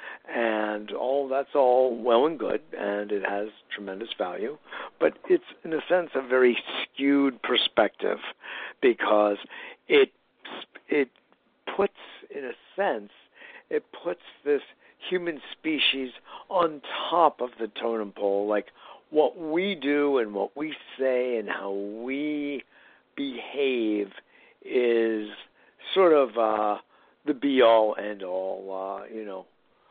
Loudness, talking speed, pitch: -26 LUFS, 125 wpm, 130 Hz